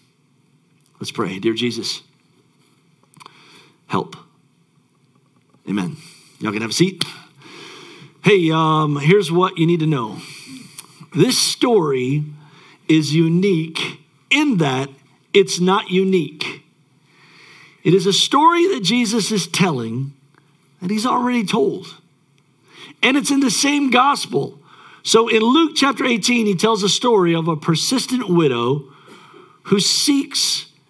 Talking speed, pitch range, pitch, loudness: 120 wpm, 150-225 Hz, 175 Hz, -17 LUFS